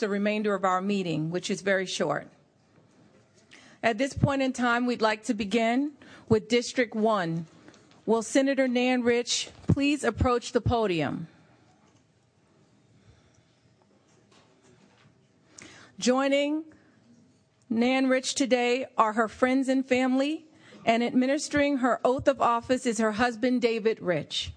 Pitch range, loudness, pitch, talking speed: 220-265 Hz, -26 LUFS, 240 Hz, 120 wpm